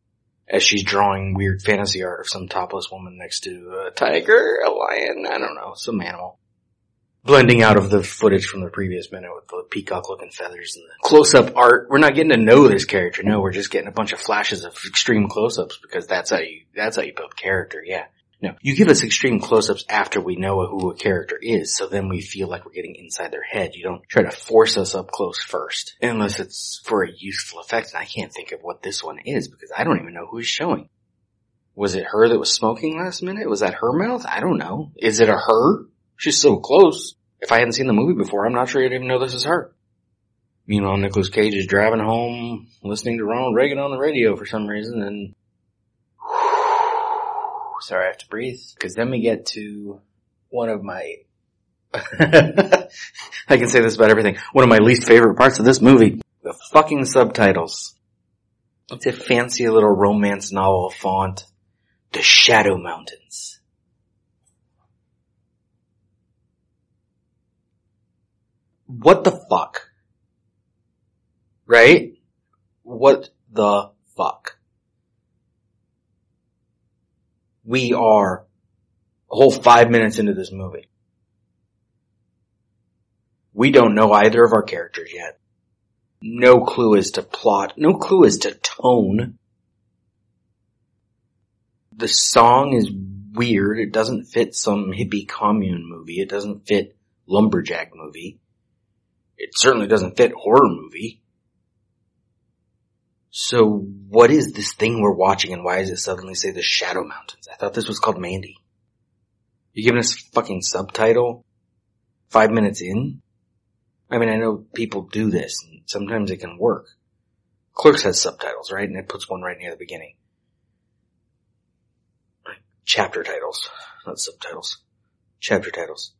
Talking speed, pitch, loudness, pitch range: 160 wpm, 110 Hz, -17 LUFS, 100-130 Hz